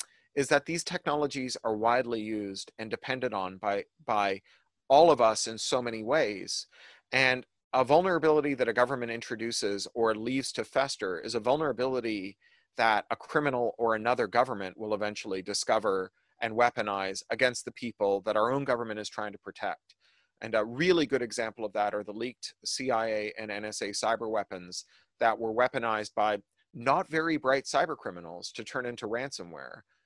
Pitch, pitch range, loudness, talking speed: 115 Hz, 105-130 Hz, -30 LUFS, 165 wpm